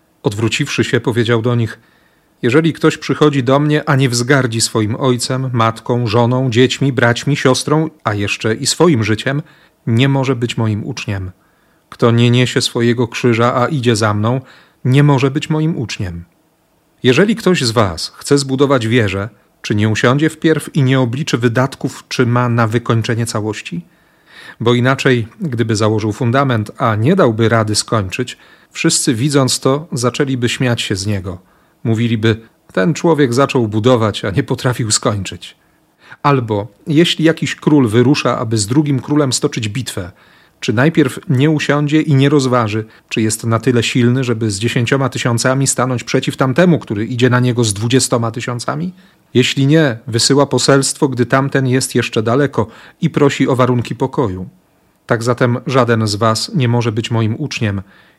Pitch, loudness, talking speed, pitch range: 125 Hz, -14 LUFS, 155 wpm, 115-145 Hz